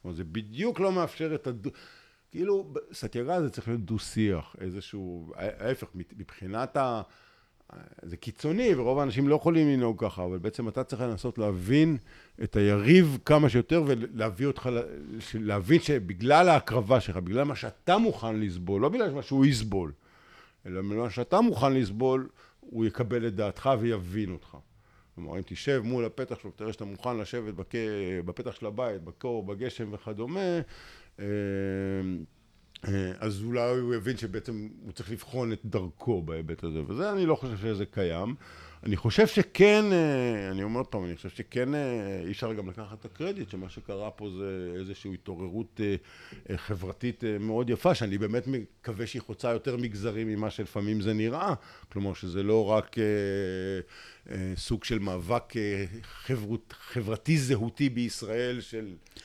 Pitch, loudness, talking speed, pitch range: 110 Hz, -29 LUFS, 150 wpm, 100-130 Hz